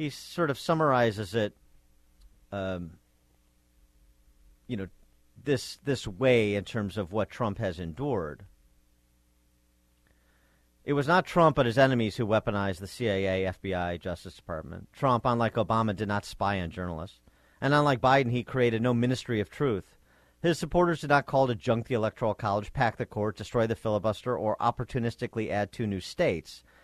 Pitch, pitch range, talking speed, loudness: 105 Hz, 85-125 Hz, 160 wpm, -28 LUFS